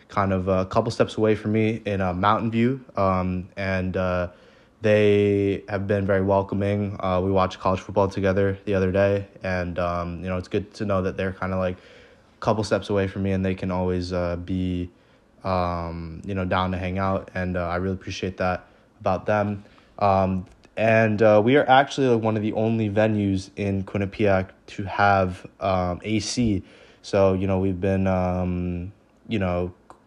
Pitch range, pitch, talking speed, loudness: 90-105 Hz, 95 Hz, 190 wpm, -23 LUFS